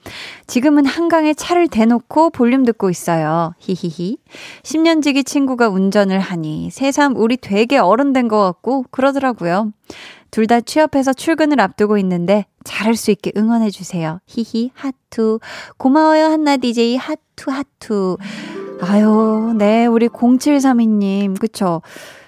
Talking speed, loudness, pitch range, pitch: 270 characters per minute, -15 LUFS, 205-275 Hz, 230 Hz